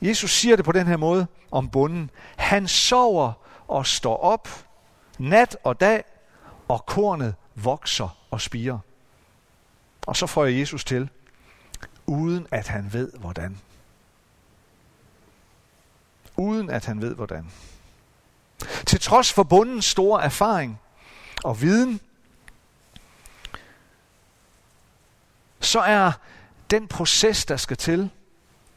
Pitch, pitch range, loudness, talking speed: 150 Hz, 120-195 Hz, -22 LUFS, 110 wpm